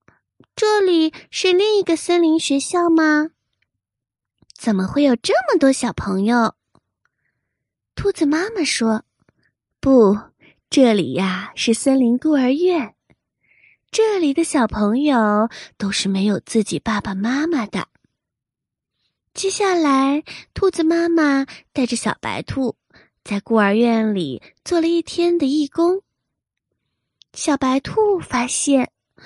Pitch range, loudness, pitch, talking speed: 225-335 Hz, -18 LUFS, 275 Hz, 170 characters per minute